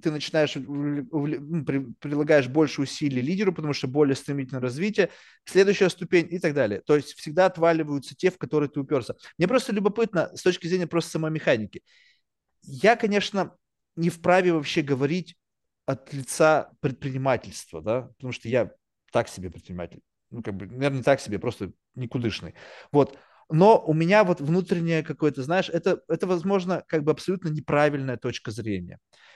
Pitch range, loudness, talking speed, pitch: 135-175 Hz, -25 LUFS, 155 wpm, 150 Hz